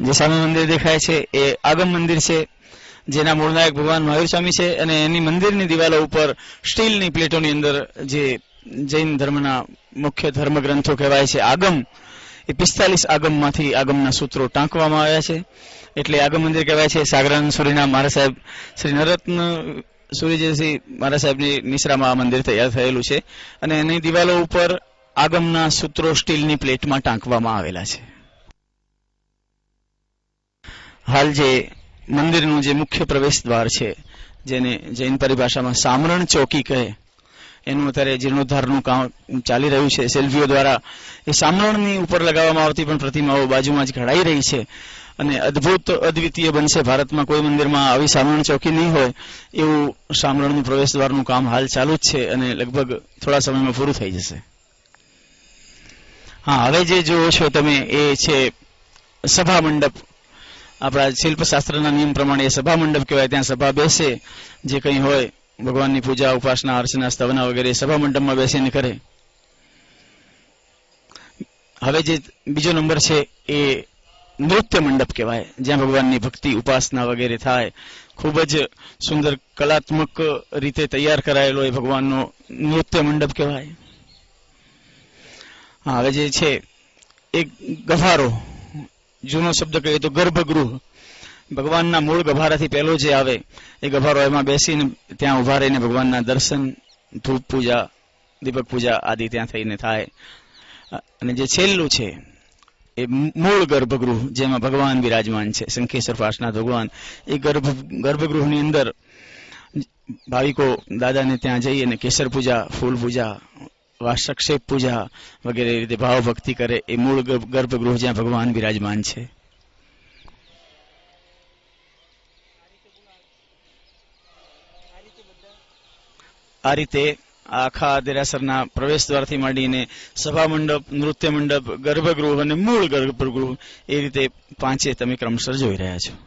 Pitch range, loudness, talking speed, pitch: 130-155 Hz, -18 LUFS, 125 wpm, 140 Hz